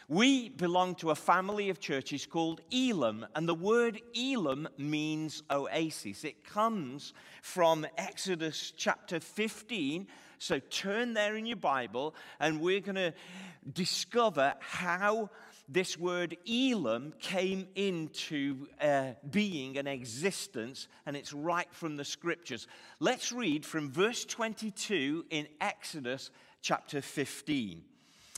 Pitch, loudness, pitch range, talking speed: 175 Hz, -34 LUFS, 150-210 Hz, 125 wpm